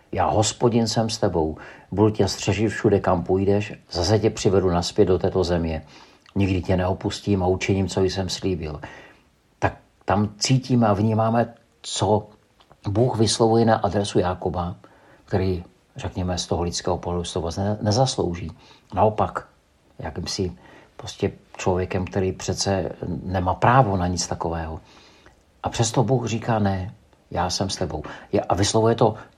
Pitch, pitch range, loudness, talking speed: 95 Hz, 90-110 Hz, -23 LUFS, 145 wpm